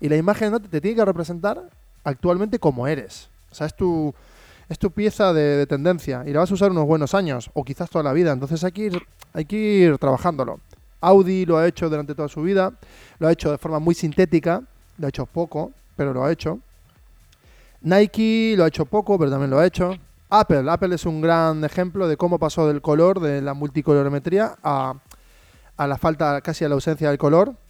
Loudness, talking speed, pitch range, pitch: -21 LUFS, 215 wpm, 150-185 Hz, 165 Hz